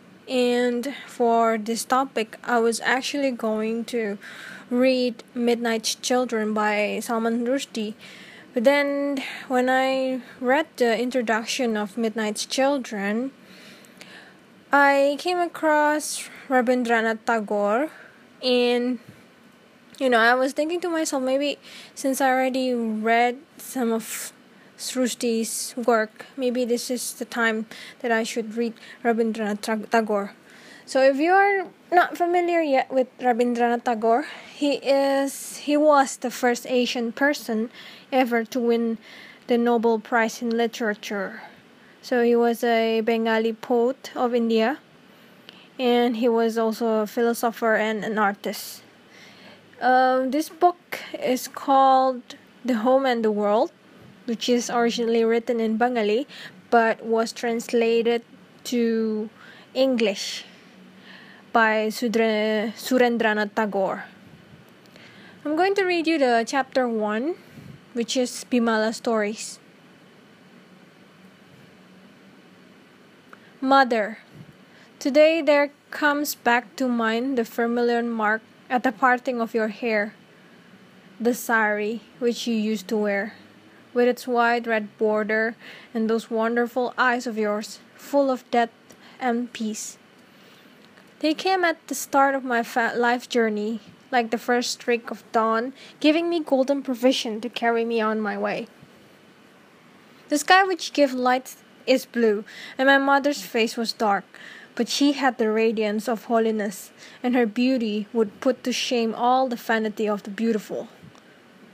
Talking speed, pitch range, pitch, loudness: 125 wpm, 220-255 Hz, 235 Hz, -23 LUFS